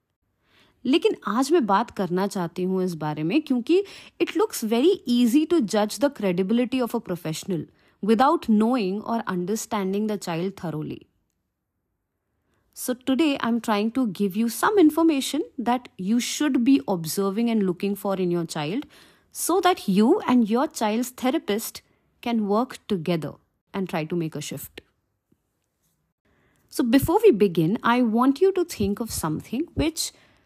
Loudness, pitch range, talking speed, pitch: -23 LUFS, 185-265 Hz, 155 wpm, 220 Hz